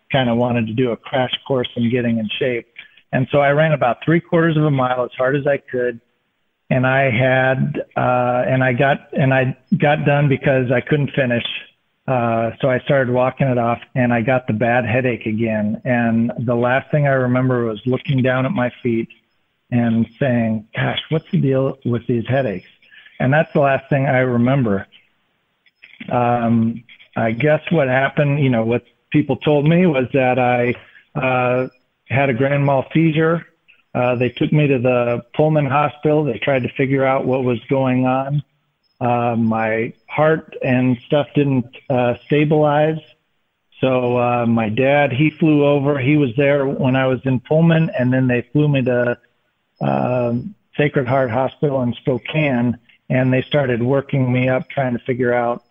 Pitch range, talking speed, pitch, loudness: 120-145 Hz, 180 wpm, 130 Hz, -18 LUFS